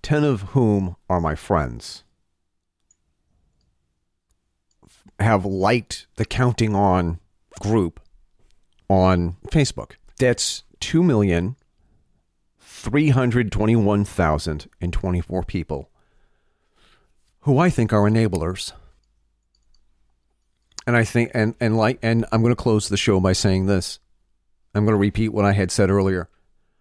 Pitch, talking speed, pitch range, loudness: 95 Hz, 125 wpm, 85-110 Hz, -21 LUFS